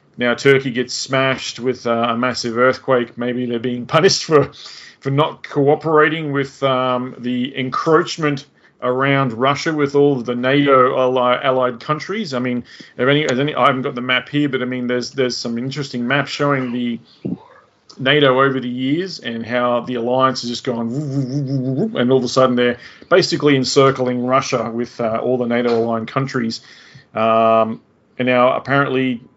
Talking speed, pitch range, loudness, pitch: 180 wpm, 125-140 Hz, -17 LUFS, 130 Hz